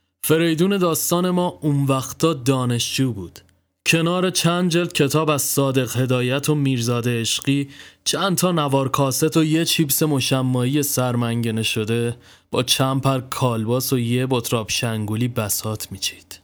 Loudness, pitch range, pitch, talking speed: -20 LUFS, 120-155 Hz, 130 Hz, 135 wpm